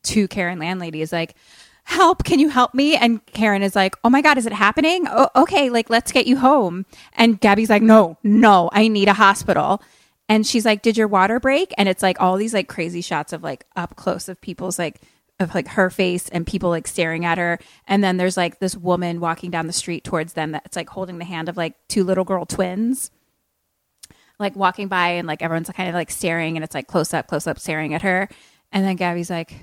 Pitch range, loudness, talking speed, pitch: 170-215 Hz, -19 LUFS, 235 wpm, 190 Hz